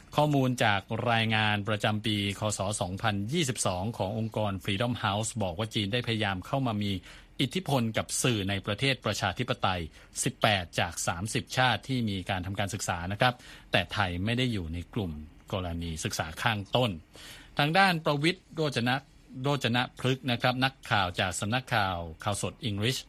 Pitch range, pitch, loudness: 100-125 Hz, 110 Hz, -29 LUFS